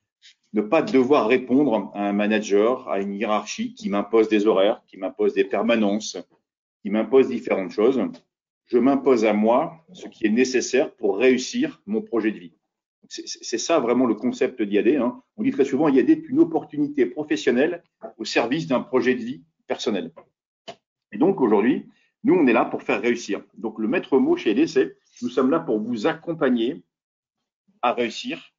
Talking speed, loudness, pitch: 180 wpm, -22 LUFS, 140 Hz